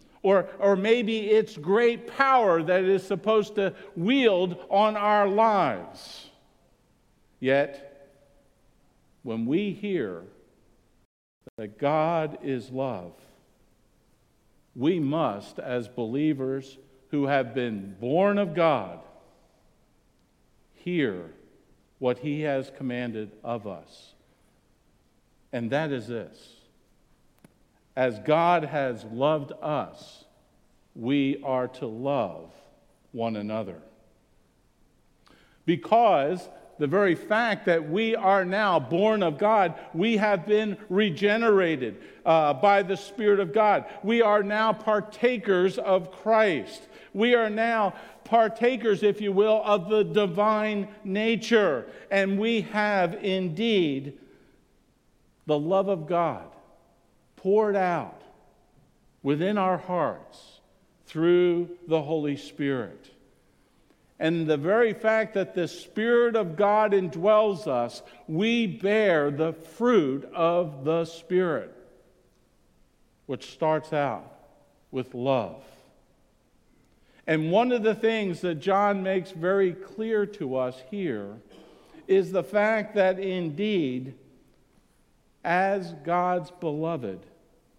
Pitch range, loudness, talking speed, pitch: 140-210 Hz, -25 LUFS, 105 wpm, 180 Hz